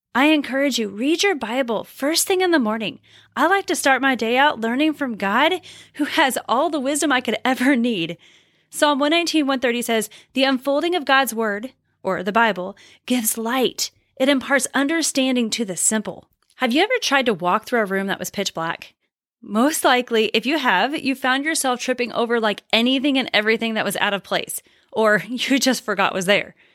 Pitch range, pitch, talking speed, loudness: 220-285 Hz, 255 Hz, 195 wpm, -20 LUFS